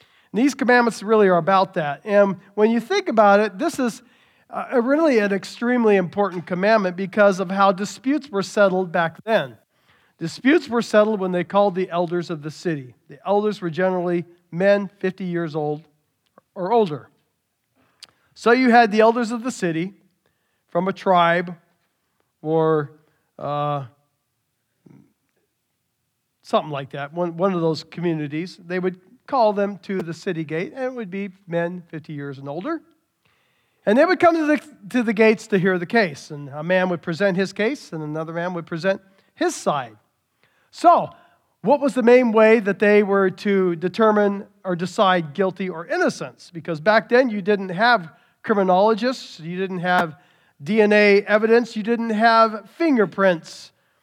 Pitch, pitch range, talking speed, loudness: 195 Hz, 170-225 Hz, 160 wpm, -20 LUFS